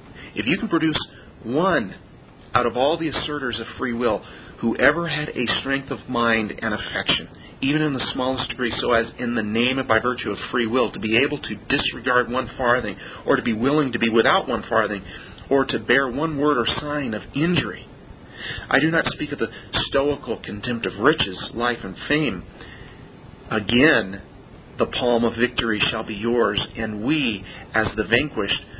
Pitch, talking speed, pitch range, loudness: 125 Hz, 185 wpm, 115-140 Hz, -22 LUFS